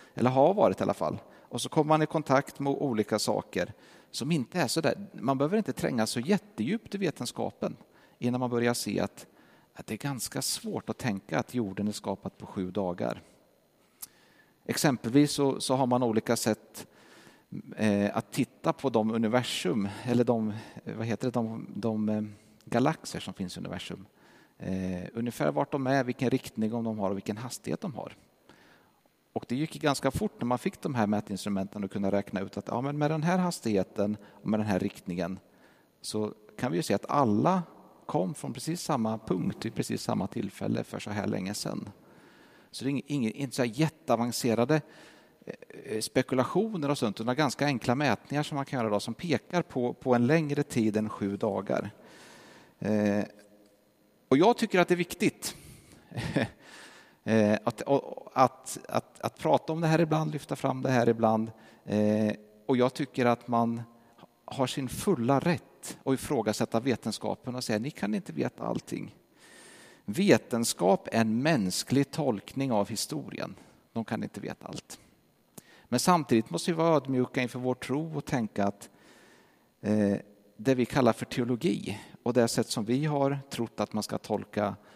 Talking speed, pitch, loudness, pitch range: 175 wpm, 120 Hz, -30 LUFS, 105-140 Hz